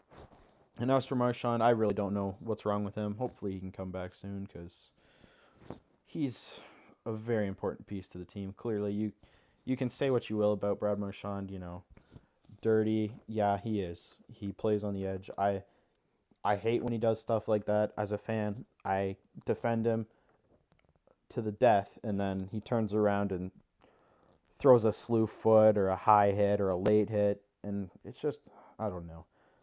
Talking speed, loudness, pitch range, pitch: 185 wpm, -32 LUFS, 100-110 Hz, 105 Hz